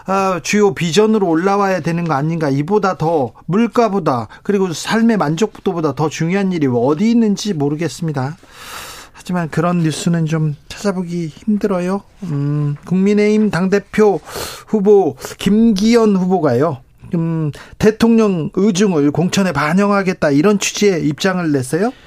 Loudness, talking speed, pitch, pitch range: -15 LUFS, 300 characters per minute, 185 Hz, 160-210 Hz